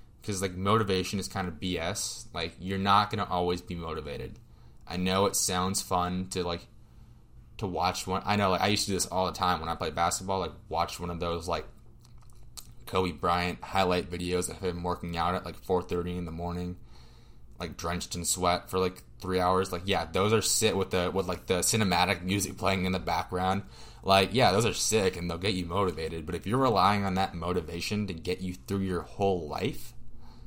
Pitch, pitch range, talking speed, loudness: 95 Hz, 90-100 Hz, 215 wpm, -29 LUFS